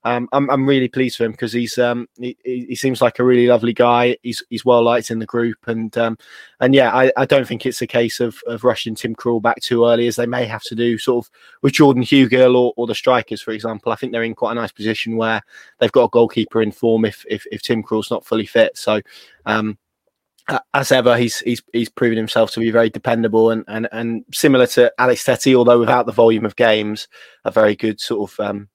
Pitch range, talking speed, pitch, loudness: 110-125 Hz, 240 wpm, 115 Hz, -17 LUFS